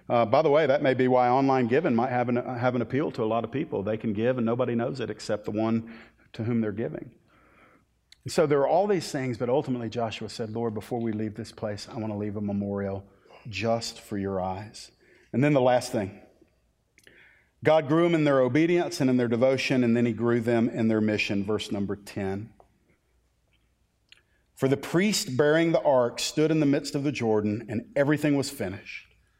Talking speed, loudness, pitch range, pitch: 215 wpm, -26 LUFS, 110-135 Hz, 115 Hz